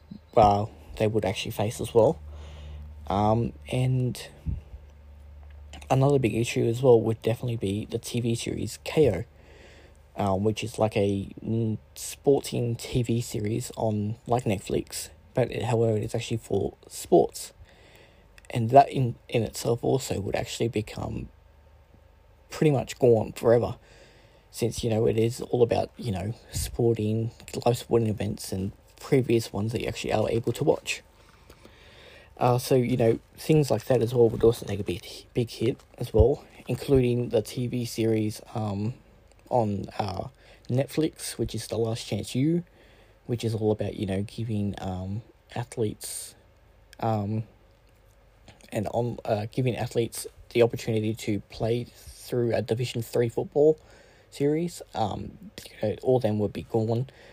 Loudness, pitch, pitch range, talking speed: -27 LUFS, 110 Hz, 100-120 Hz, 145 wpm